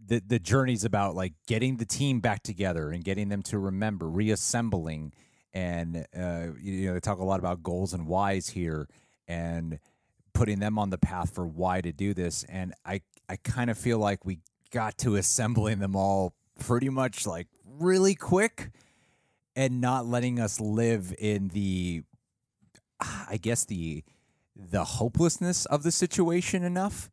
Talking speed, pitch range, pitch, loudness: 165 wpm, 90-120 Hz, 105 Hz, -29 LUFS